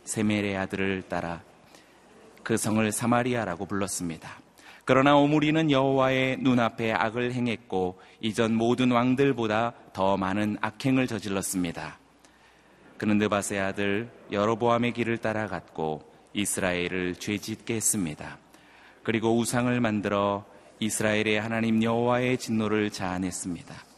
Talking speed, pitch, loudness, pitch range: 305 characters per minute, 110 Hz, -27 LUFS, 95-120 Hz